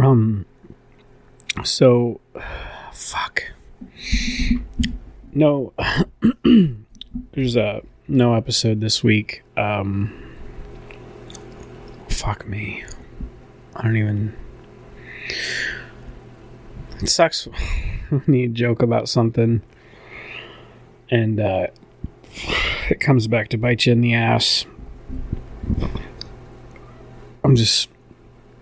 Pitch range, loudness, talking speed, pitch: 105-125 Hz, -20 LUFS, 80 wpm, 115 Hz